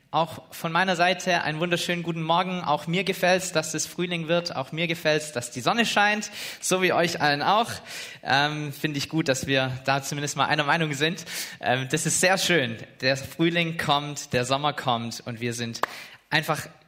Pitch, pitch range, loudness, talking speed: 155 Hz, 140-175 Hz, -25 LUFS, 200 wpm